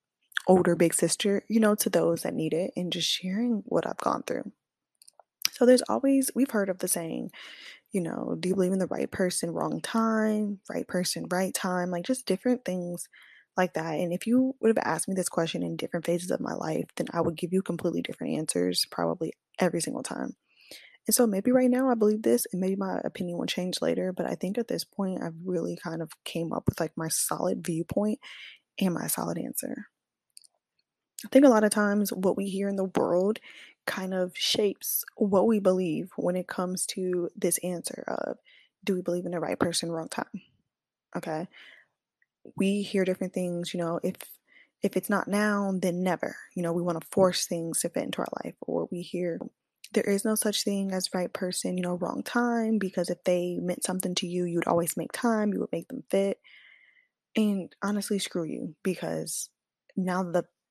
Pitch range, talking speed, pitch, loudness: 175-210 Hz, 205 wpm, 185 Hz, -28 LUFS